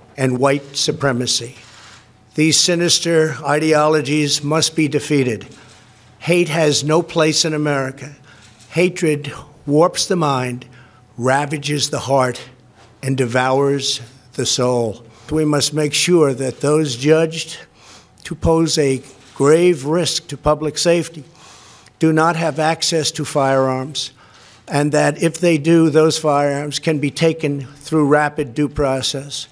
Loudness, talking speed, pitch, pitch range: -17 LUFS, 125 wpm, 145 Hz, 130-155 Hz